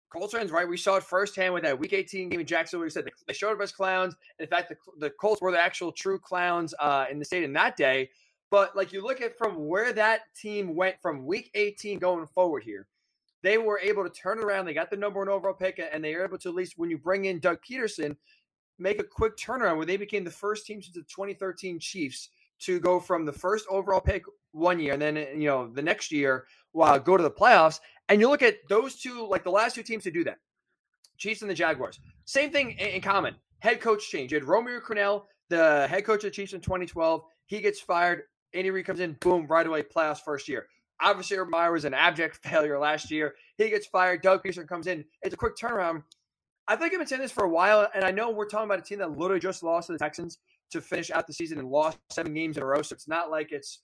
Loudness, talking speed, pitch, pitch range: -27 LUFS, 250 wpm, 185 Hz, 165-205 Hz